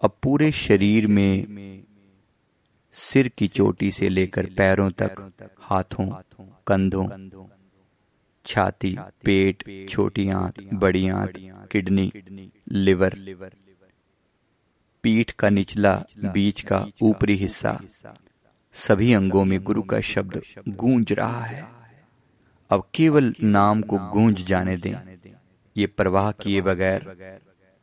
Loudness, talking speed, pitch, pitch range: -22 LUFS, 100 wpm, 100 Hz, 95-105 Hz